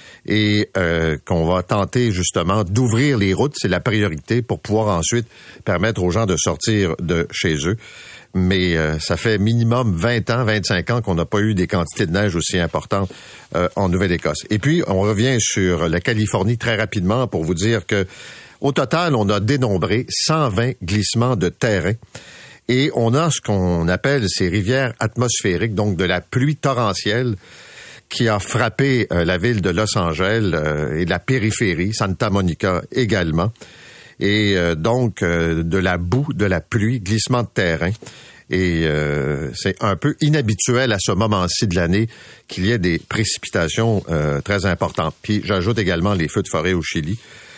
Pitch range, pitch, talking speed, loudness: 90-115 Hz, 105 Hz, 165 wpm, -19 LUFS